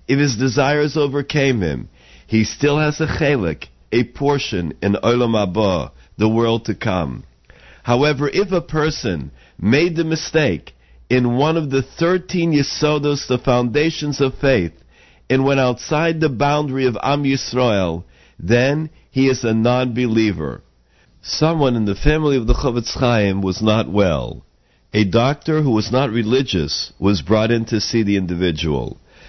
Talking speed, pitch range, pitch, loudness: 150 wpm, 100-145 Hz, 125 Hz, -18 LUFS